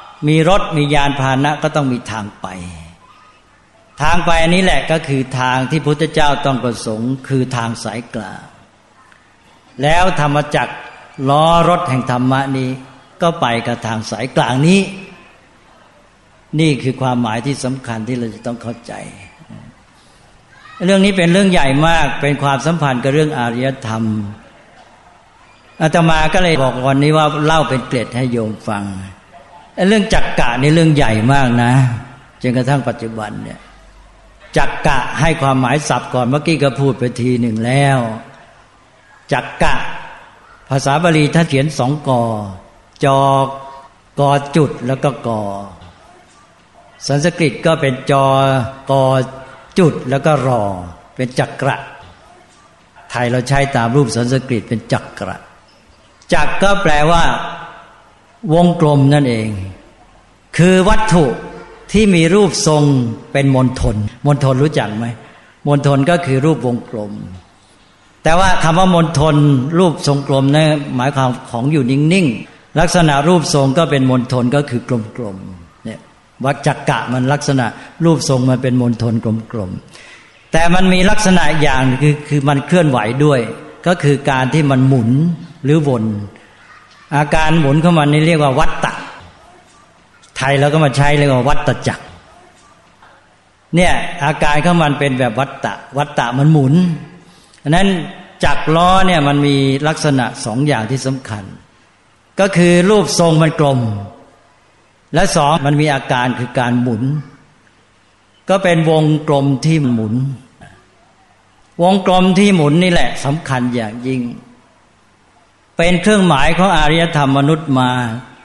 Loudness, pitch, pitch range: -14 LUFS, 140 Hz, 125-155 Hz